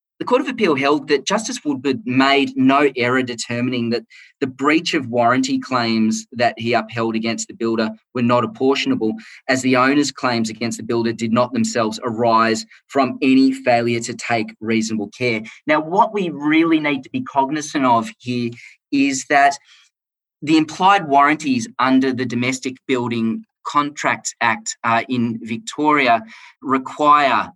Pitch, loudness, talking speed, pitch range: 130 Hz, -18 LUFS, 150 wpm, 115-145 Hz